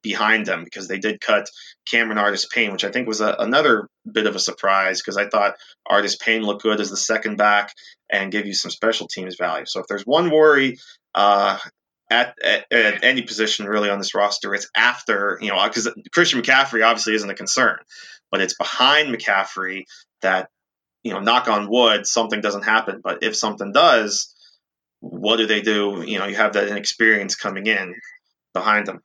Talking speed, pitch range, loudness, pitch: 195 wpm, 100-110 Hz, -19 LUFS, 105 Hz